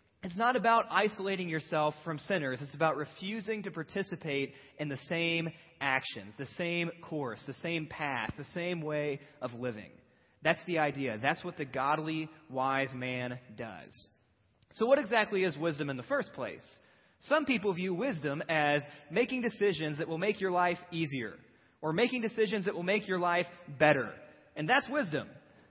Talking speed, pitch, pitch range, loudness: 165 wpm, 160 Hz, 140-190 Hz, -33 LUFS